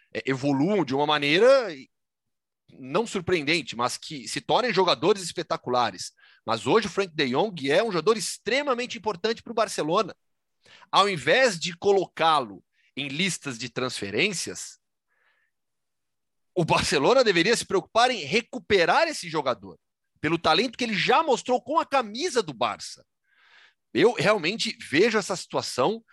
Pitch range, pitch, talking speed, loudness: 165-255 Hz, 210 Hz, 135 wpm, -24 LUFS